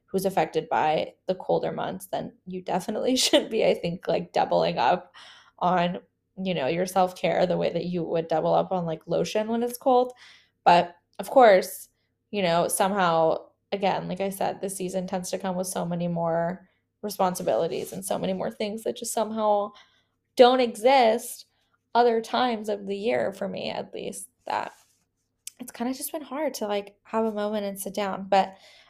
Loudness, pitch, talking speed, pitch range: -25 LUFS, 200 Hz, 185 wpm, 180-230 Hz